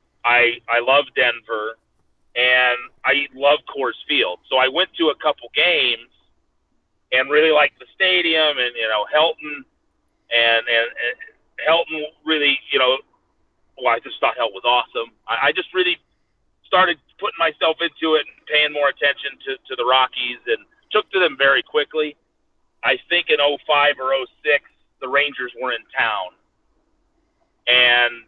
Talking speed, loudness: 155 wpm, -18 LUFS